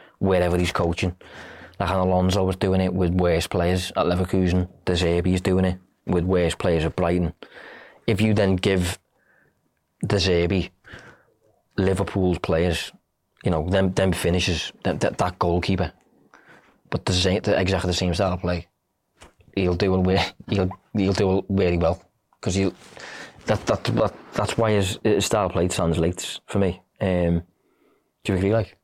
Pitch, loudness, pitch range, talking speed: 95 Hz, -23 LUFS, 90-95 Hz, 165 wpm